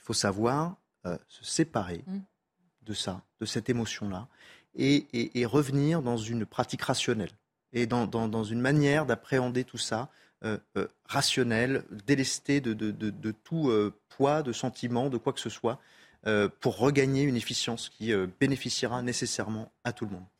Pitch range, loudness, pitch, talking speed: 110-135 Hz, -30 LUFS, 120 Hz, 175 wpm